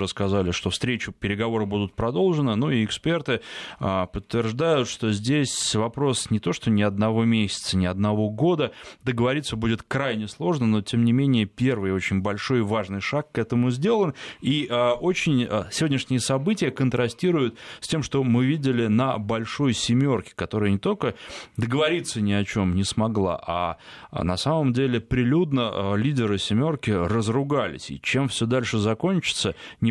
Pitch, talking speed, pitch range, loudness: 115 Hz, 165 wpm, 105-135 Hz, -24 LUFS